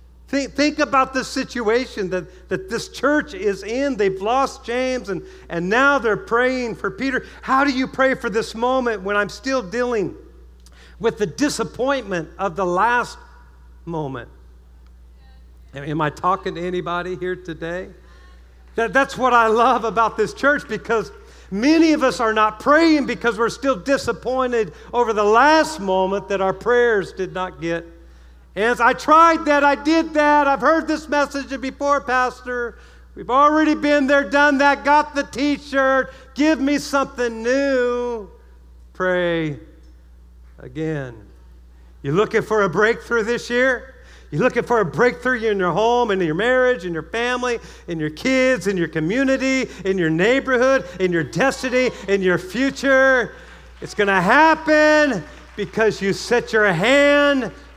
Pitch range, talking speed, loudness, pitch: 185-265 Hz, 155 wpm, -19 LUFS, 235 Hz